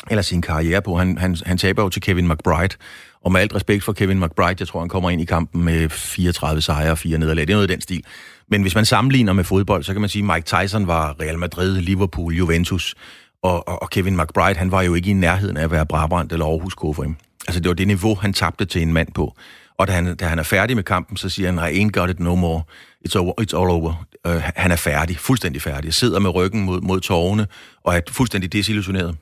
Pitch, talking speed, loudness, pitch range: 90 Hz, 255 wpm, -19 LUFS, 85-100 Hz